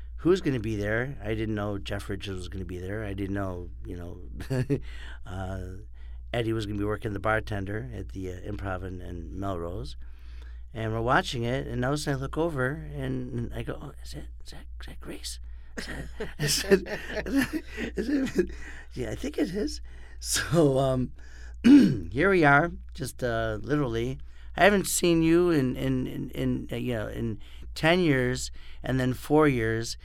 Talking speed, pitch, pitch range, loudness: 190 wpm, 110 Hz, 85-130 Hz, -27 LUFS